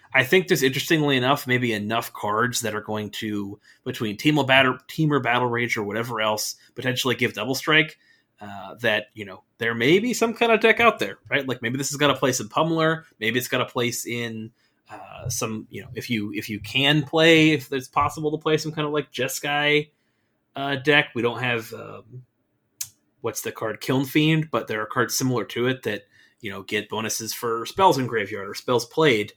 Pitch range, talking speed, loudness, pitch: 115-150 Hz, 215 wpm, -22 LUFS, 125 Hz